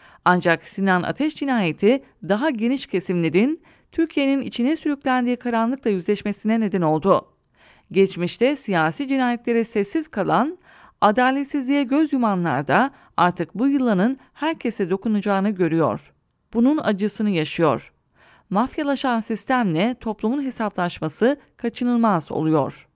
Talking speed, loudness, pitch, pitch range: 100 wpm, -21 LUFS, 225 Hz, 190-265 Hz